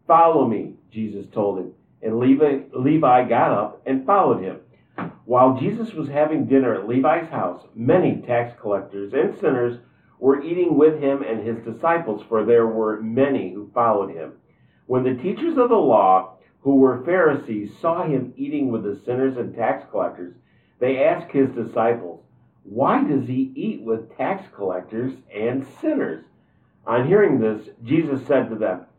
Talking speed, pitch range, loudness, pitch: 160 wpm, 110-140 Hz, -21 LUFS, 130 Hz